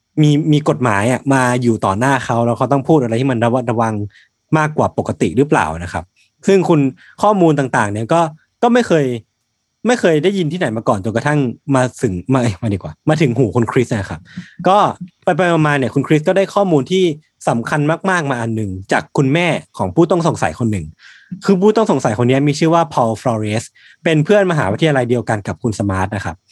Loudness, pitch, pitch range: -15 LUFS, 135 Hz, 115-165 Hz